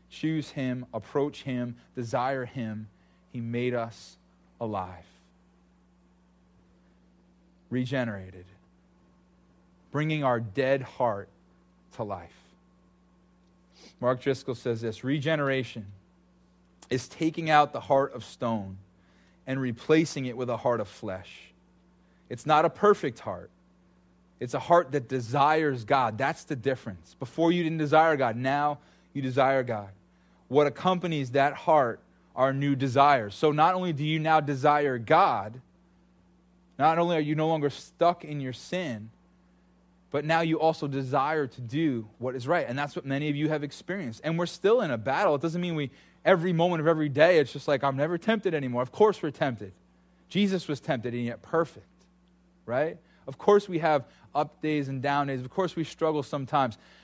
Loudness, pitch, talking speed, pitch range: -27 LUFS, 140 Hz, 160 wpm, 115-160 Hz